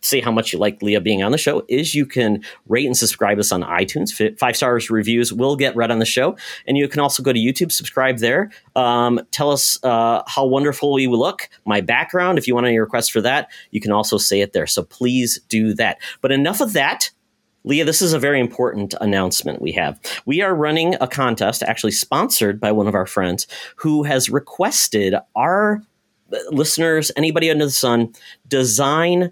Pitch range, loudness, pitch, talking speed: 115-145 Hz, -18 LUFS, 130 Hz, 205 wpm